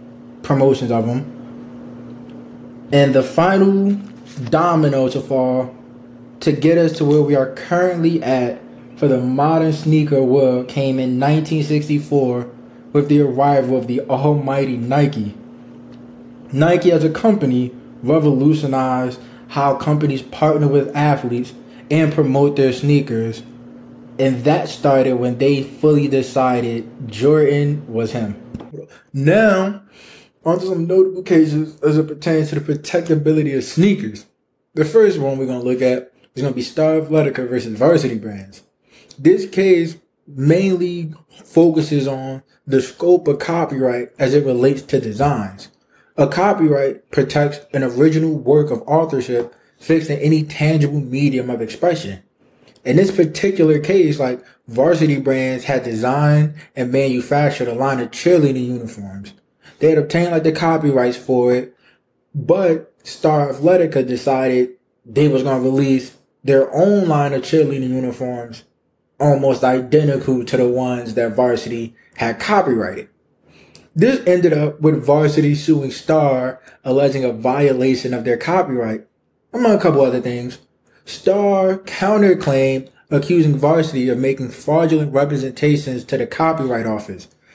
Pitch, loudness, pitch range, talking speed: 140 Hz, -16 LUFS, 125-155 Hz, 130 wpm